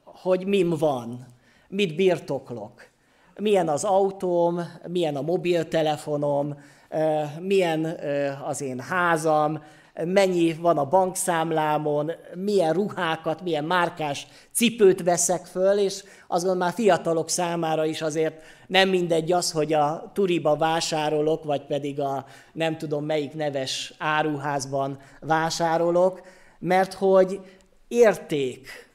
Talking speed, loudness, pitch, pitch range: 110 wpm, -24 LUFS, 160 Hz, 150-180 Hz